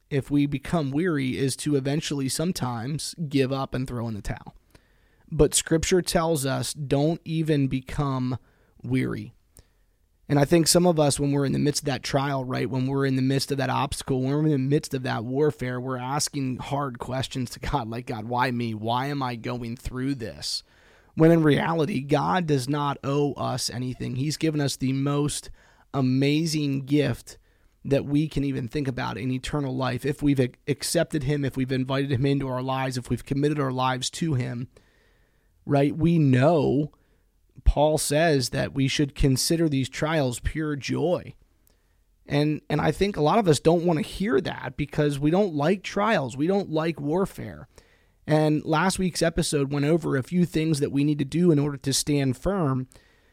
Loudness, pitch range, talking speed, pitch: -25 LUFS, 130-150 Hz, 190 wpm, 140 Hz